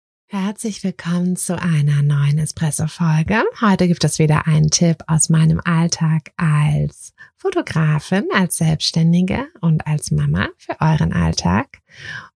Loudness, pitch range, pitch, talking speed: -17 LUFS, 155-180 Hz, 160 Hz, 120 wpm